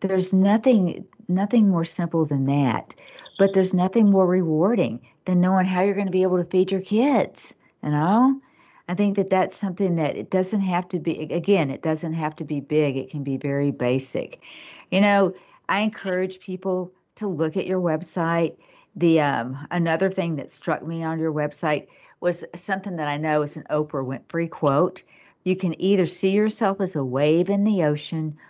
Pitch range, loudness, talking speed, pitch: 155-190 Hz, -23 LUFS, 190 wpm, 180 Hz